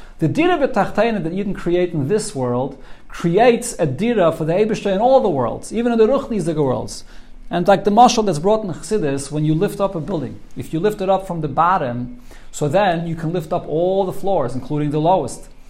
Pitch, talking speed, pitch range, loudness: 180 Hz, 230 wpm, 150-210 Hz, -18 LUFS